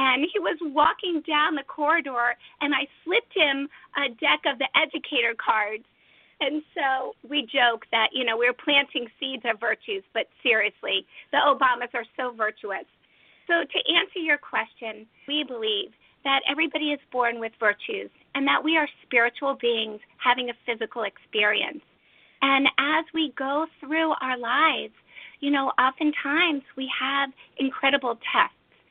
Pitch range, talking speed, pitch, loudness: 245-310 Hz, 150 wpm, 275 Hz, -24 LUFS